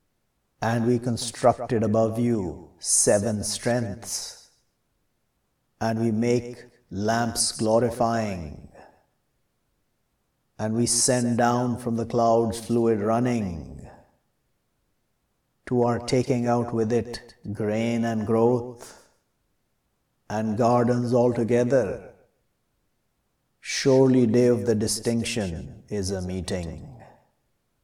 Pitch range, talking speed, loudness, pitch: 110-120 Hz, 90 wpm, -24 LUFS, 115 Hz